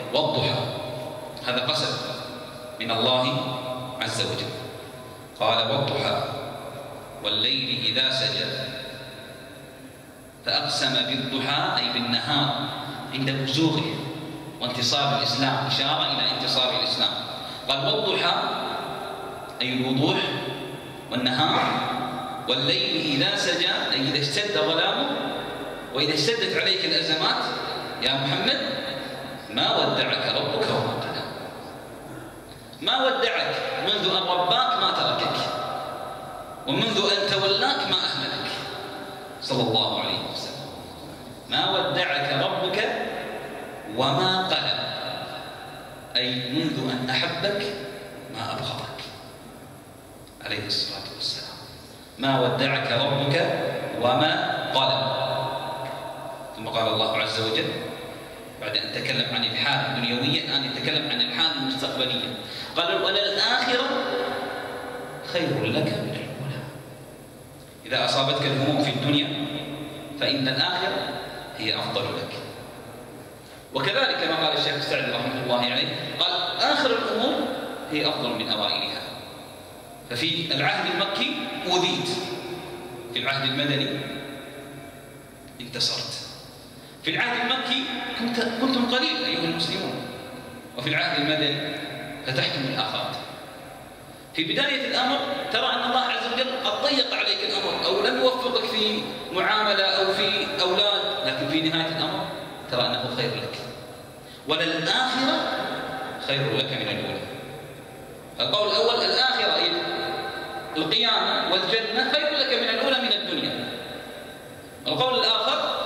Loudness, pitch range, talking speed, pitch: -24 LUFS, 130-185 Hz, 100 wpm, 140 Hz